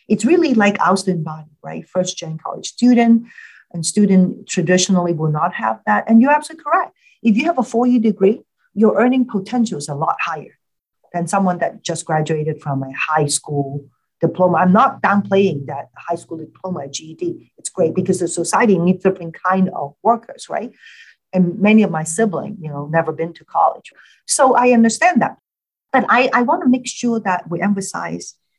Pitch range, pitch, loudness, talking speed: 165-225 Hz, 185 Hz, -17 LUFS, 185 wpm